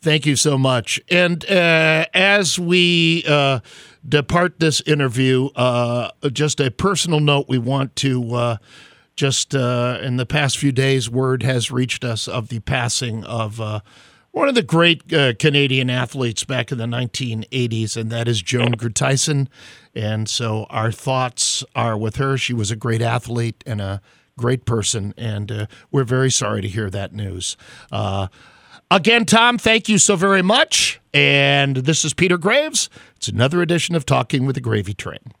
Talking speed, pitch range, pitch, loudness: 170 wpm, 115-150 Hz, 130 Hz, -18 LUFS